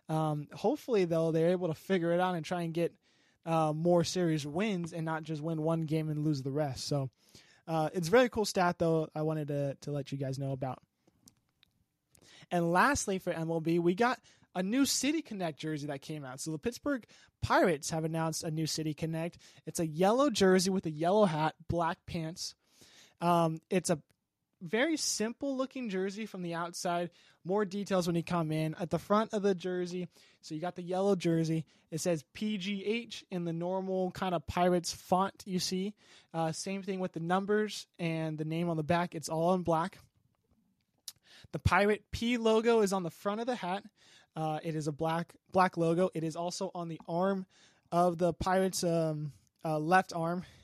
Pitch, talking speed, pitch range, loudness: 175 Hz, 195 wpm, 160-190 Hz, -32 LUFS